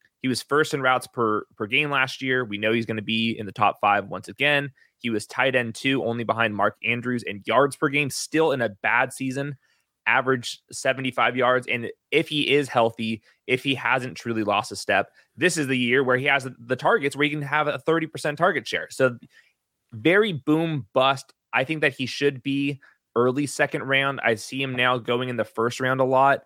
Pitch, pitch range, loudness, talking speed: 130 Hz, 115-140 Hz, -23 LUFS, 220 wpm